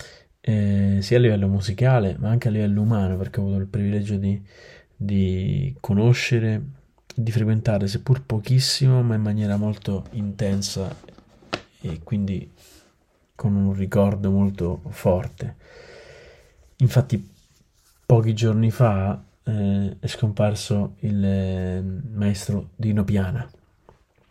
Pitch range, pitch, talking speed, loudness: 100-120 Hz, 105 Hz, 115 wpm, -23 LUFS